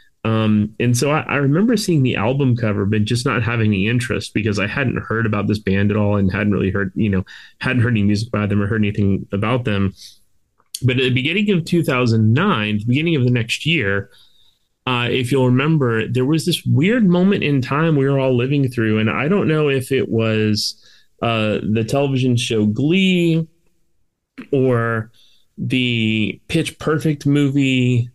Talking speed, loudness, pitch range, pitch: 185 wpm, -18 LUFS, 105-140 Hz, 120 Hz